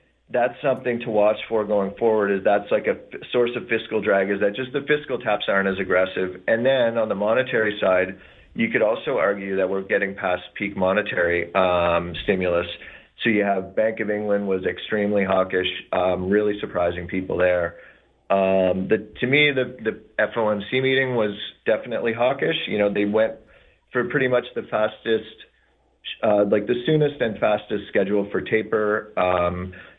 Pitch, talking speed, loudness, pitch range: 105 Hz, 175 wpm, -22 LUFS, 95-110 Hz